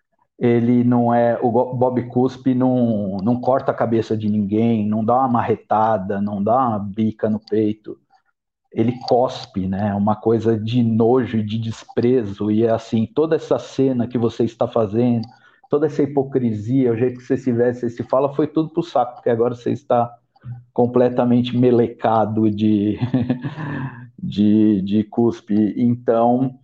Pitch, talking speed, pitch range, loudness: 120 Hz, 160 wpm, 110-125 Hz, -19 LUFS